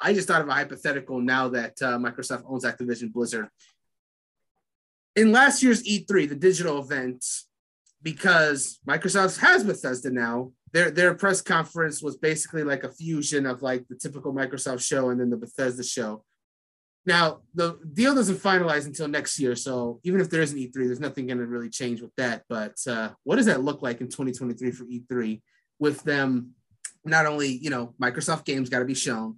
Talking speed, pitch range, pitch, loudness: 185 wpm, 125-160 Hz, 135 Hz, -25 LUFS